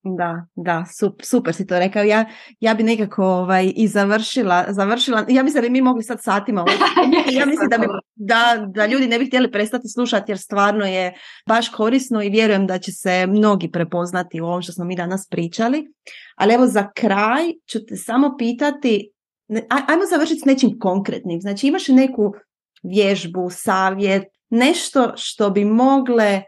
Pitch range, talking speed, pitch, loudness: 195-250 Hz, 175 wpm, 215 Hz, -18 LUFS